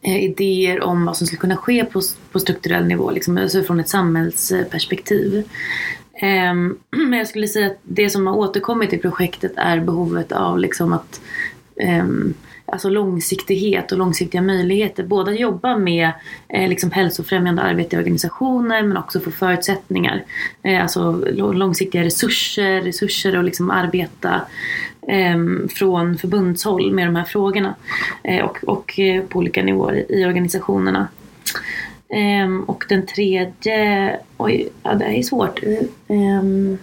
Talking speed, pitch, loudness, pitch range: 135 wpm, 190 Hz, -18 LUFS, 180-200 Hz